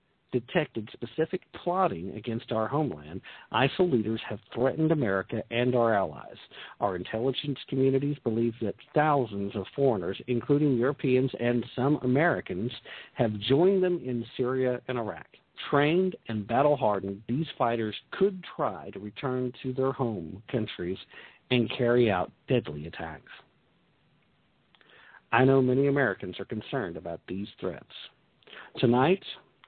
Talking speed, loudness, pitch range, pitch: 125 wpm, -28 LUFS, 110-140 Hz, 125 Hz